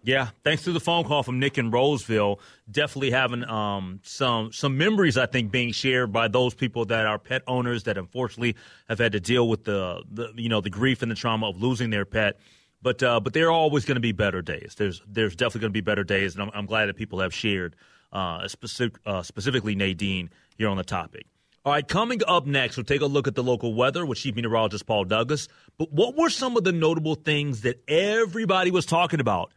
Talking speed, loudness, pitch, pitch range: 235 wpm, -25 LUFS, 120 Hz, 105-140 Hz